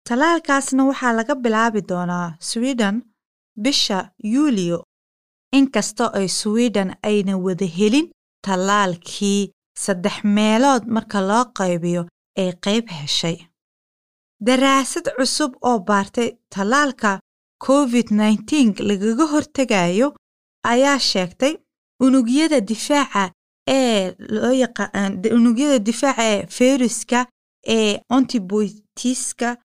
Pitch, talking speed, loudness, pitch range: 225 Hz, 90 wpm, -19 LUFS, 200-260 Hz